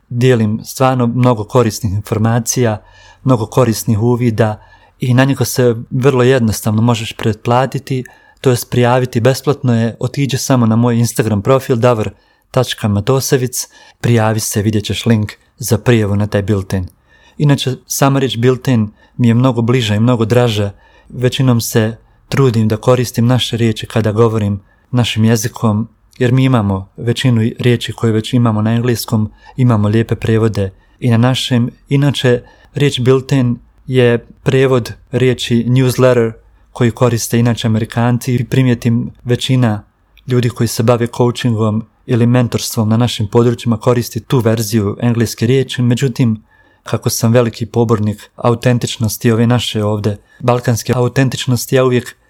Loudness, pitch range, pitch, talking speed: -14 LUFS, 110-125 Hz, 120 Hz, 135 wpm